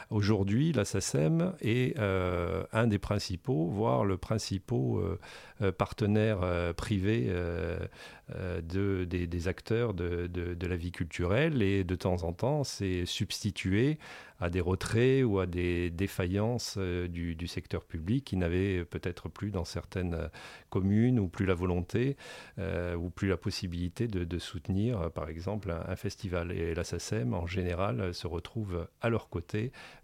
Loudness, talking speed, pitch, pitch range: -32 LUFS, 155 wpm, 95 Hz, 90-110 Hz